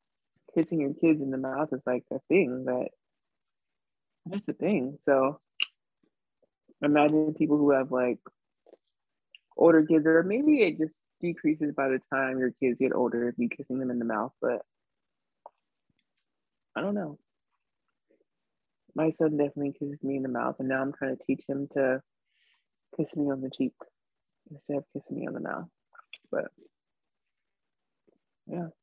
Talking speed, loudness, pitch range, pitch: 155 wpm, -28 LUFS, 130-155 Hz, 140 Hz